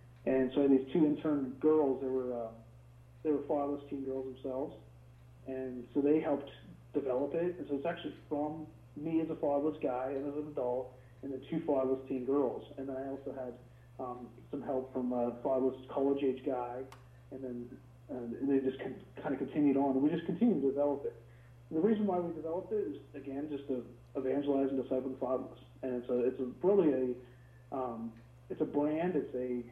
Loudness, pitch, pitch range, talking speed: -35 LUFS, 130 Hz, 125-145 Hz, 200 wpm